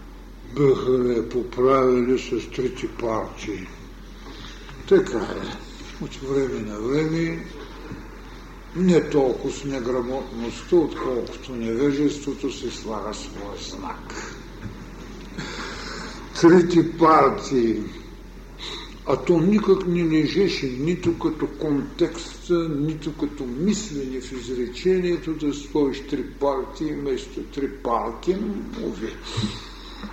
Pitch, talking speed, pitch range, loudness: 145 Hz, 85 wpm, 130-170 Hz, -23 LUFS